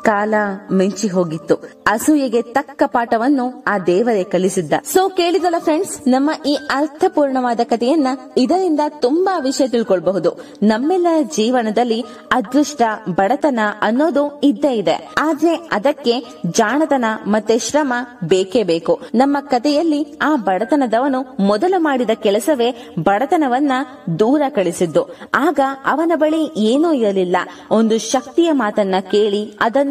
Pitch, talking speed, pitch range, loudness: 250 Hz, 110 wpm, 210-295 Hz, -17 LUFS